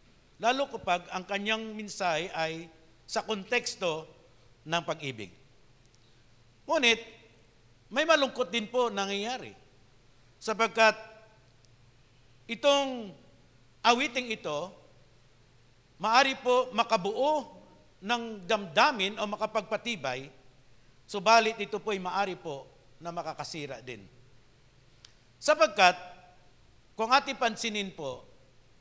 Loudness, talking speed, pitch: -29 LUFS, 85 wpm, 185 Hz